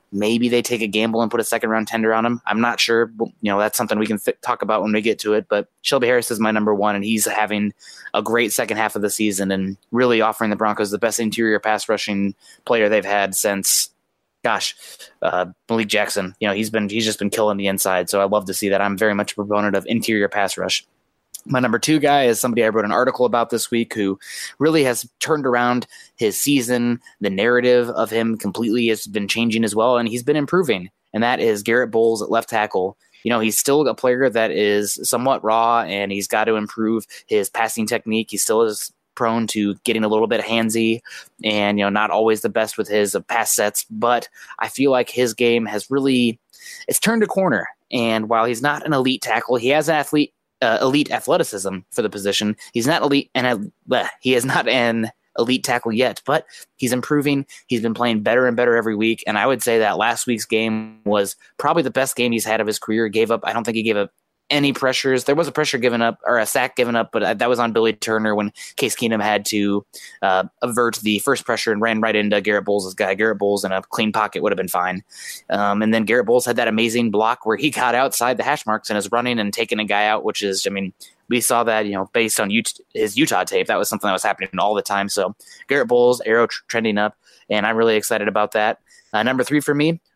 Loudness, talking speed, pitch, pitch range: -19 LUFS, 245 wpm, 115 Hz, 105-120 Hz